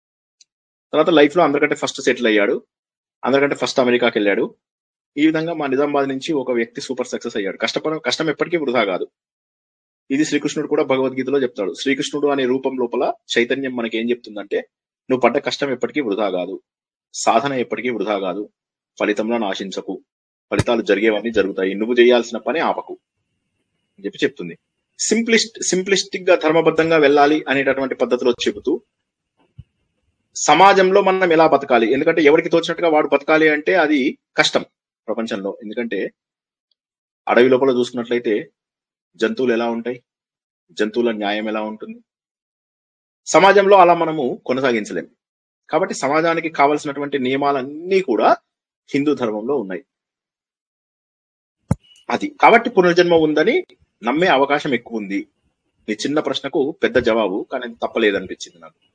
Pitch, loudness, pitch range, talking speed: 140 Hz, -18 LUFS, 120-165 Hz, 125 wpm